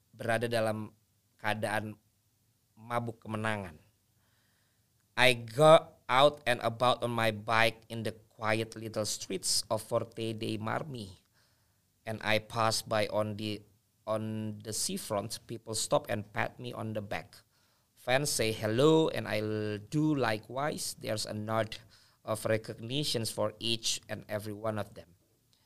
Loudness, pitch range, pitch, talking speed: -31 LUFS, 105-115 Hz, 110 Hz, 135 wpm